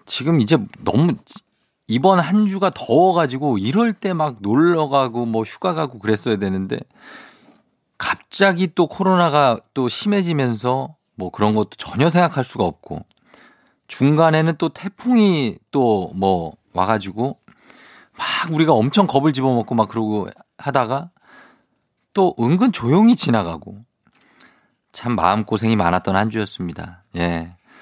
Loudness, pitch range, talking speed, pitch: -18 LUFS, 110-180 Hz, 265 characters per minute, 135 Hz